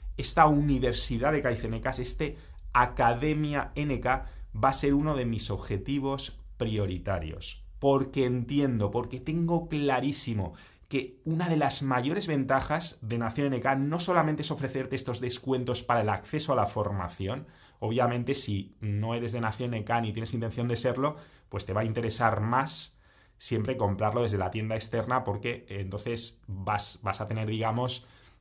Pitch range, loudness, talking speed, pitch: 110-135 Hz, -28 LUFS, 155 wpm, 125 Hz